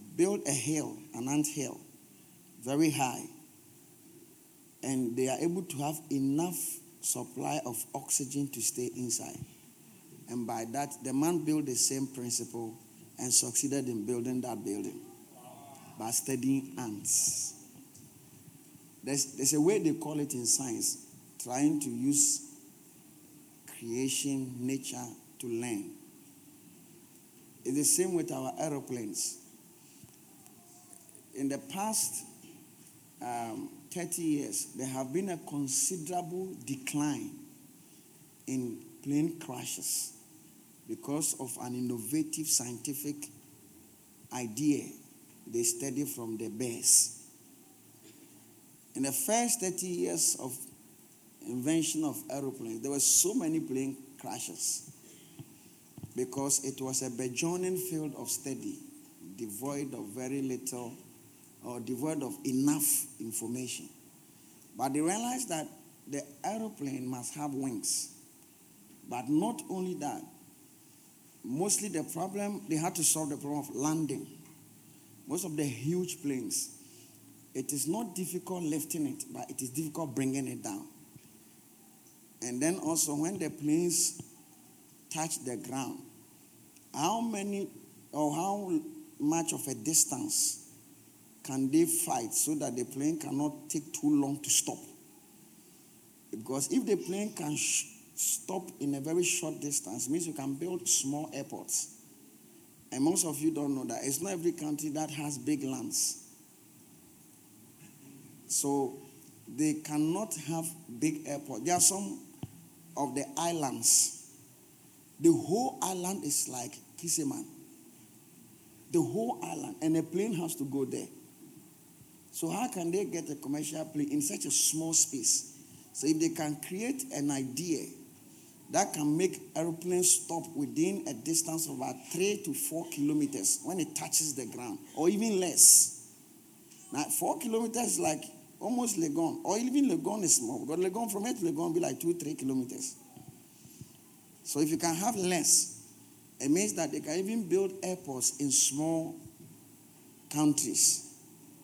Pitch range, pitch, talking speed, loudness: 135-185 Hz, 155 Hz, 135 wpm, -31 LUFS